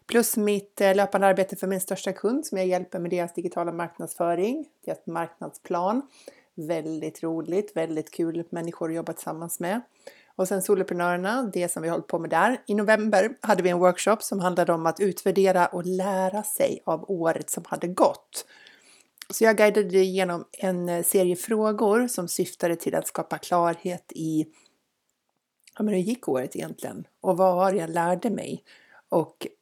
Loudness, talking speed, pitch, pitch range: -25 LUFS, 170 wpm, 185 Hz, 170-210 Hz